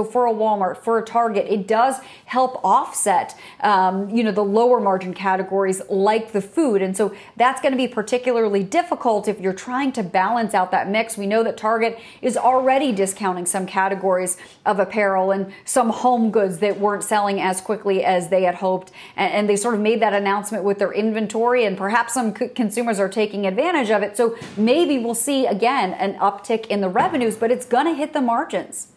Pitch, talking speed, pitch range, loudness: 215 Hz, 200 wpm, 195-235 Hz, -20 LUFS